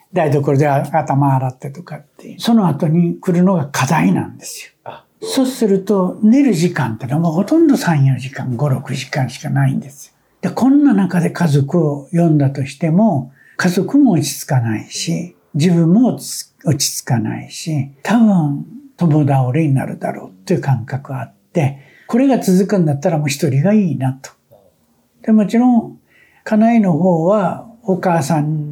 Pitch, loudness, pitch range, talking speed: 165 Hz, -15 LUFS, 140-200 Hz, 305 characters per minute